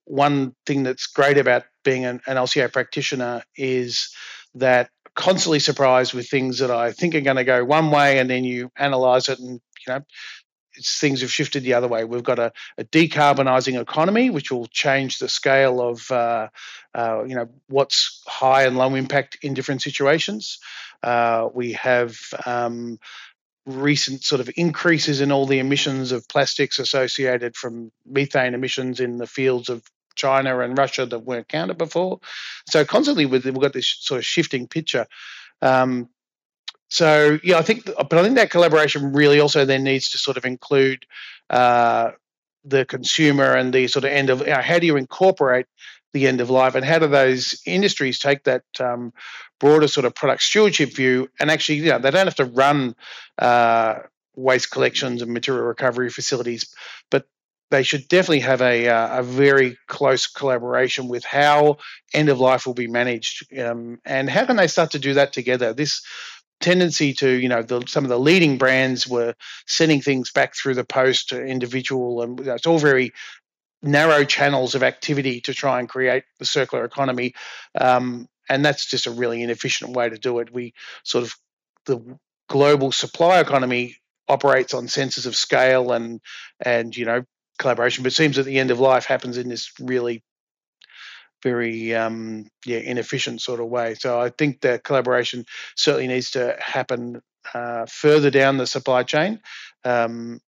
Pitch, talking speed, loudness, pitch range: 130 Hz, 180 wpm, -19 LUFS, 125-140 Hz